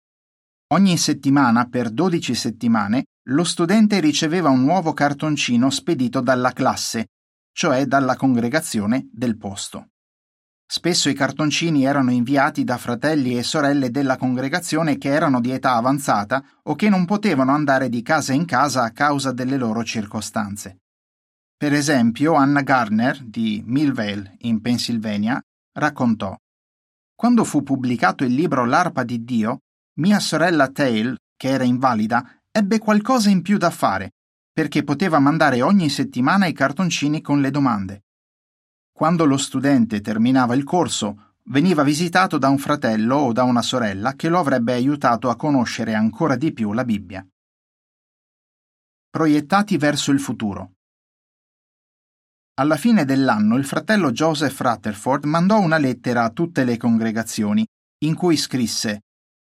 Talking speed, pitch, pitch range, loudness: 135 wpm, 135 Hz, 120-160 Hz, -19 LUFS